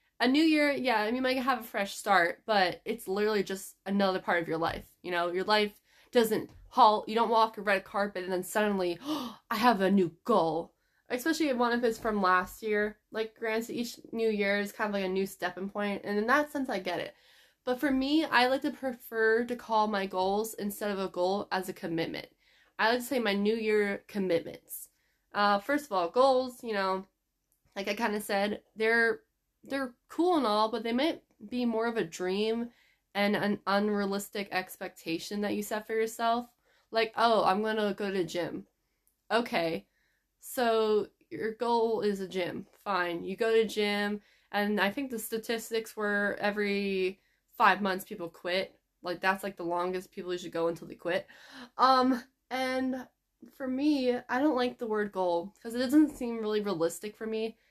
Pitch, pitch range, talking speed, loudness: 215 Hz, 195-235 Hz, 200 wpm, -30 LUFS